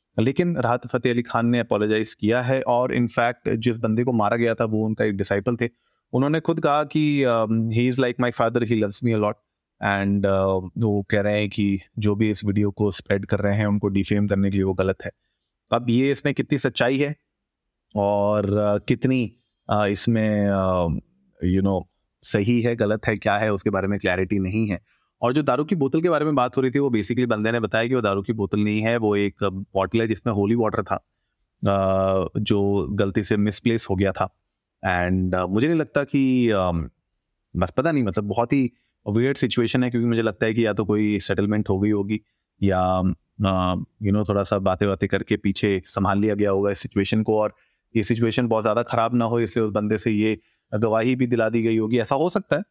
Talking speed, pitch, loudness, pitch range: 215 wpm, 110 Hz, -22 LUFS, 100-120 Hz